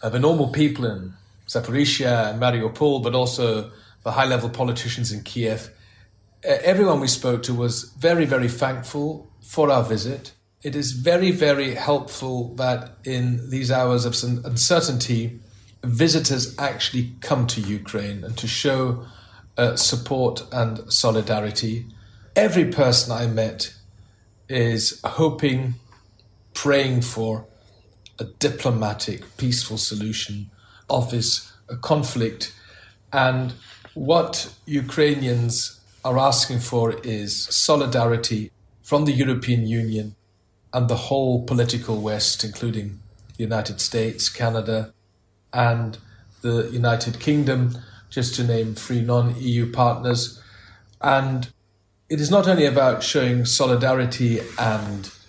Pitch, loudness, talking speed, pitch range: 120 Hz, -22 LUFS, 115 wpm, 110-130 Hz